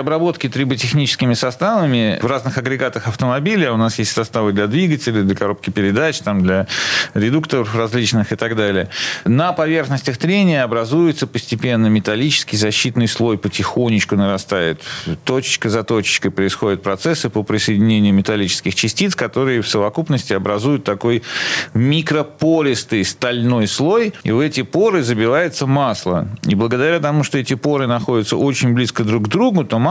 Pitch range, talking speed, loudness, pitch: 110-140 Hz, 140 wpm, -16 LUFS, 120 Hz